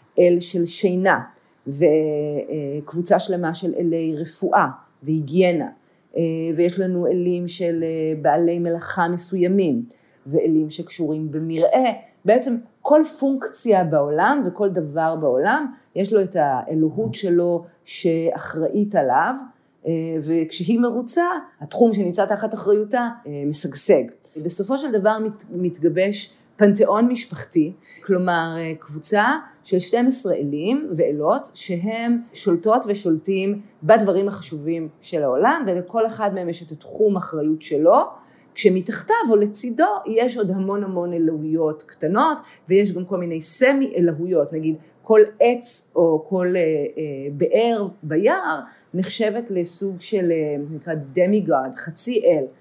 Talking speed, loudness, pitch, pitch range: 110 wpm, -20 LUFS, 180 Hz, 160-215 Hz